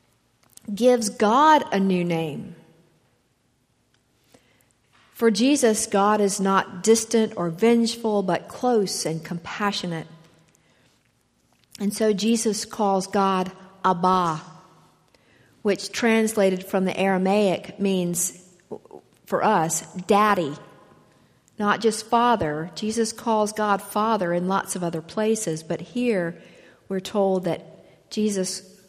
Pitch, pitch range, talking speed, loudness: 195 Hz, 180-220 Hz, 105 wpm, -23 LUFS